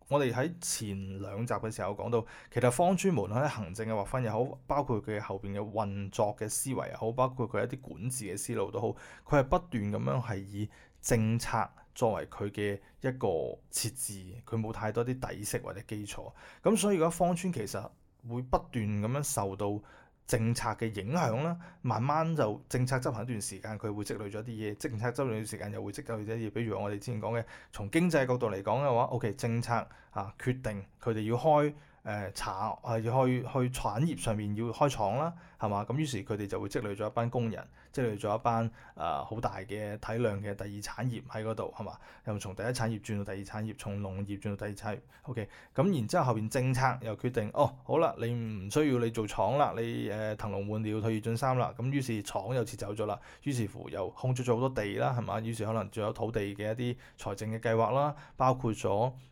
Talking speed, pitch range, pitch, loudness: 315 characters per minute, 105-125 Hz, 115 Hz, -33 LUFS